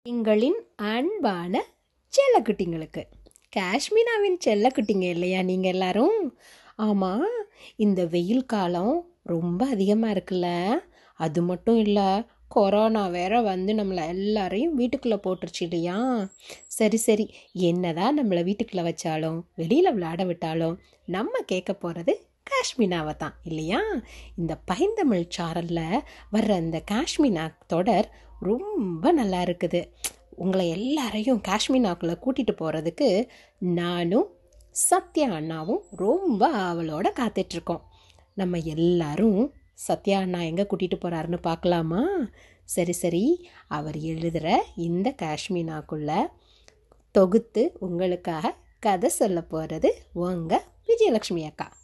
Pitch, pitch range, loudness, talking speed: 190 Hz, 175-245 Hz, -25 LUFS, 95 wpm